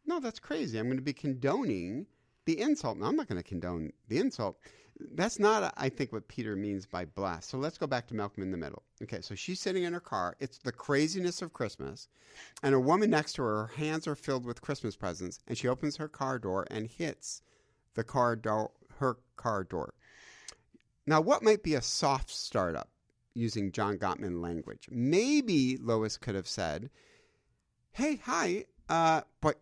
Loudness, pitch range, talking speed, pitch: -33 LUFS, 105-155 Hz, 190 wpm, 130 Hz